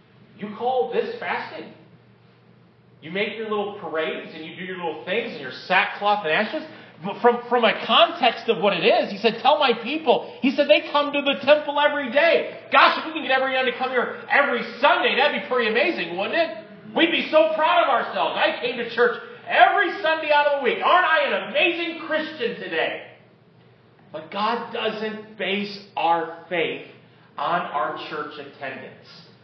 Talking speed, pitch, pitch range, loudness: 190 wpm, 250 Hz, 210-300 Hz, -21 LUFS